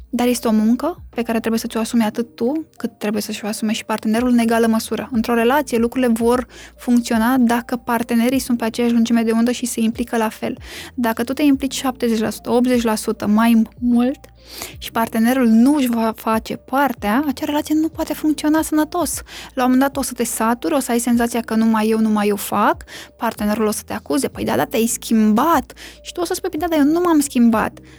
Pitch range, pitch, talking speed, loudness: 225-260 Hz, 235 Hz, 220 wpm, -18 LUFS